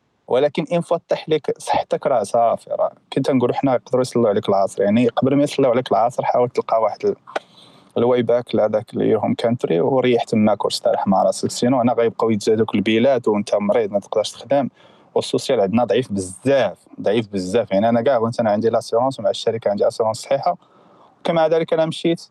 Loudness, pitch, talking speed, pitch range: -19 LUFS, 125 Hz, 185 wpm, 115-160 Hz